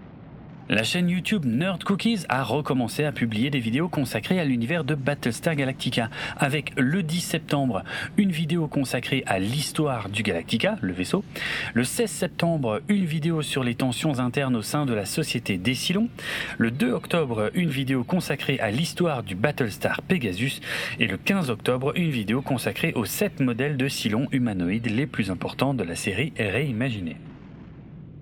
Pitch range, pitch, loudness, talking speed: 120-165 Hz, 140 Hz, -25 LUFS, 165 wpm